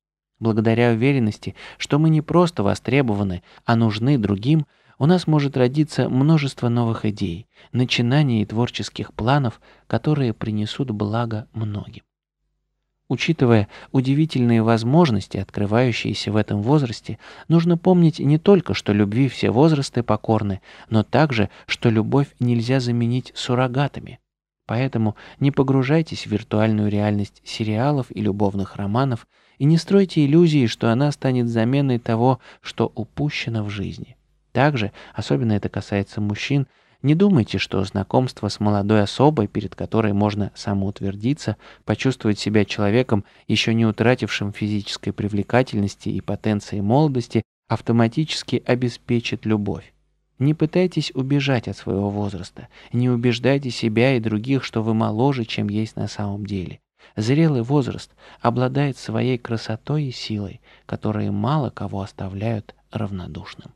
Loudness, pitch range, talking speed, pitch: -21 LUFS, 105-135 Hz, 125 wpm, 115 Hz